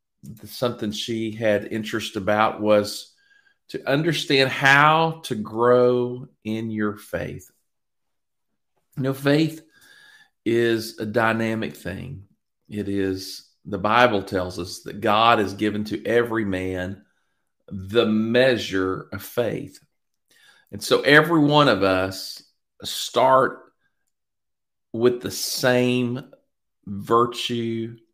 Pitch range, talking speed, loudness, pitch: 105-125 Hz, 105 wpm, -21 LUFS, 115 Hz